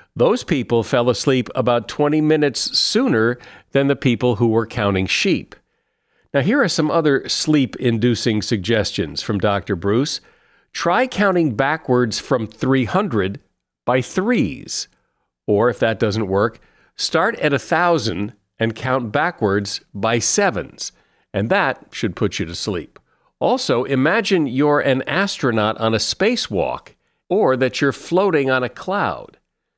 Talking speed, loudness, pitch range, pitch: 135 wpm, -19 LUFS, 110-145 Hz, 125 Hz